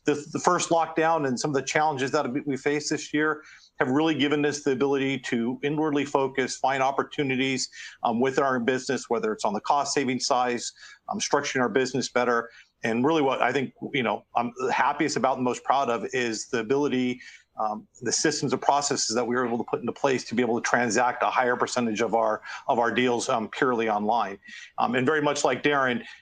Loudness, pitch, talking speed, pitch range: -25 LUFS, 135 Hz, 215 wpm, 125-145 Hz